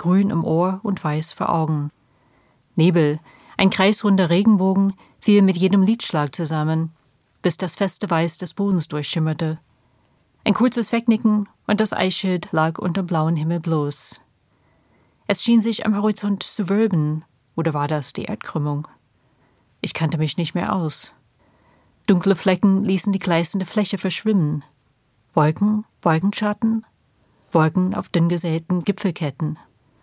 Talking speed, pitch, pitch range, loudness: 130 wpm, 170 Hz, 150-200 Hz, -21 LUFS